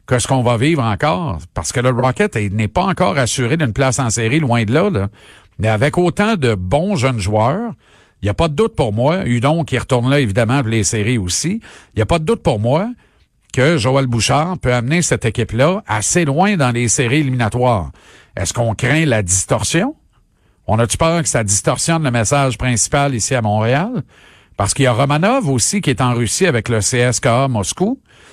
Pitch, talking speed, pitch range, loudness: 130 Hz, 210 wpm, 115-155 Hz, -16 LUFS